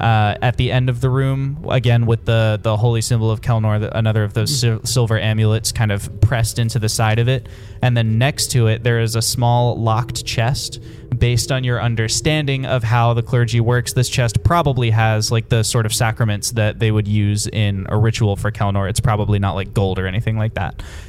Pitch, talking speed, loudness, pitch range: 115 Hz, 220 wpm, -17 LUFS, 110-120 Hz